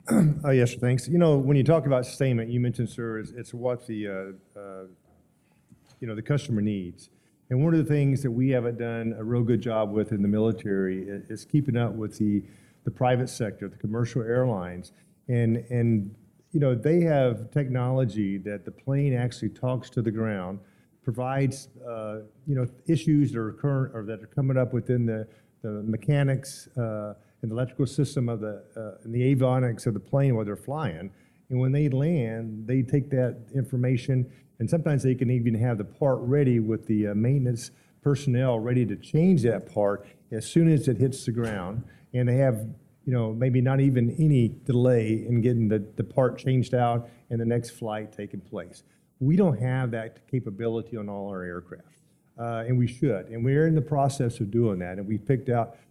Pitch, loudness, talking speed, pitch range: 120 Hz, -26 LUFS, 200 wpm, 110-130 Hz